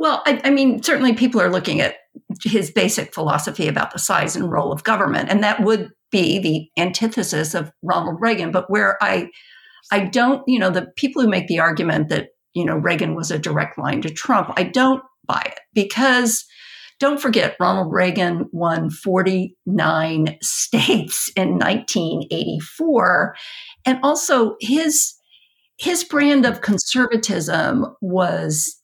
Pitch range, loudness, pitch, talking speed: 180-260 Hz, -19 LUFS, 220 Hz, 150 wpm